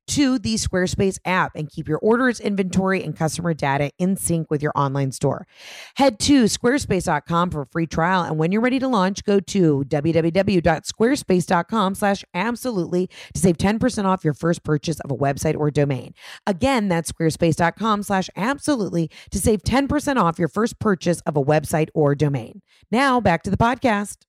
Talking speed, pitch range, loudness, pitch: 165 wpm, 160-215 Hz, -21 LUFS, 180 Hz